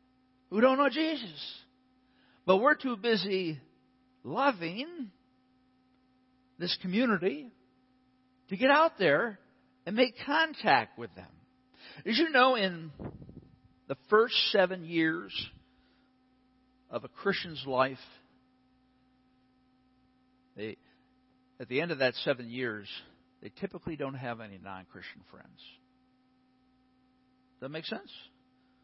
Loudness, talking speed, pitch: -30 LUFS, 105 wpm, 185 Hz